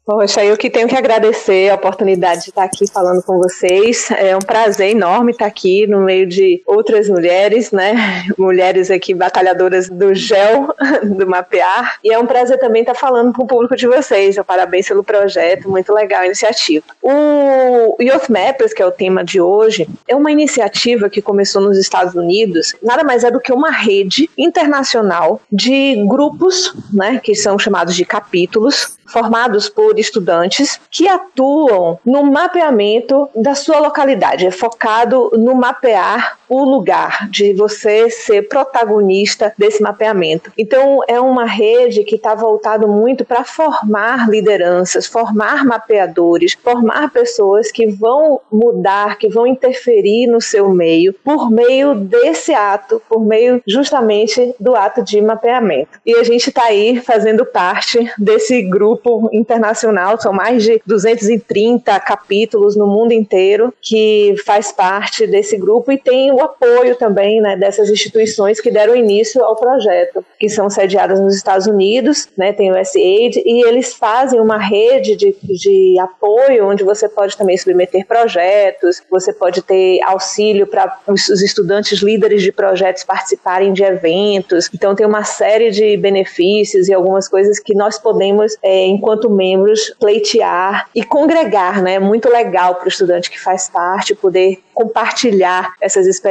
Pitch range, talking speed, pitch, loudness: 195-245 Hz, 155 wpm, 215 Hz, -12 LUFS